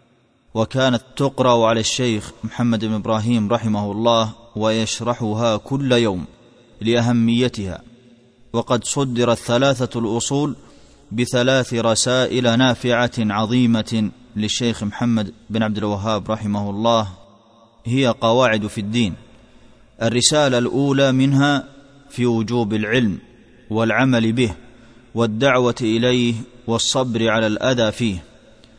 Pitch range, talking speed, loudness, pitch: 110-125 Hz, 95 wpm, -19 LUFS, 115 Hz